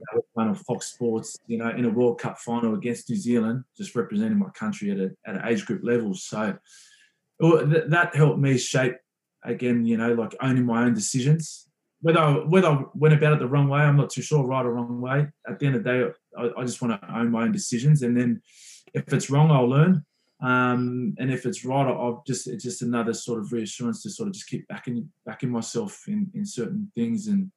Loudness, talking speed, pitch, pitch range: -24 LUFS, 230 wpm, 130 Hz, 120-165 Hz